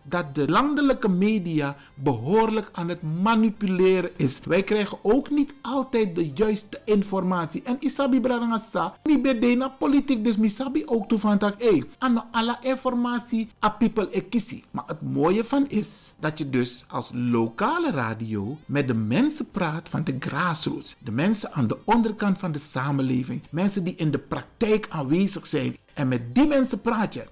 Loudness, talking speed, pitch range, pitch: -24 LUFS, 155 wpm, 155-235 Hz, 205 Hz